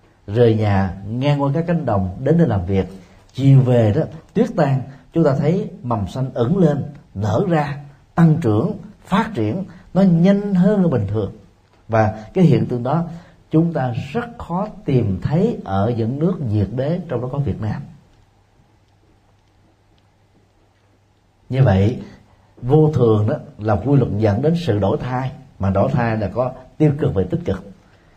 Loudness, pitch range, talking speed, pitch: -18 LUFS, 105-155 Hz, 165 wpm, 125 Hz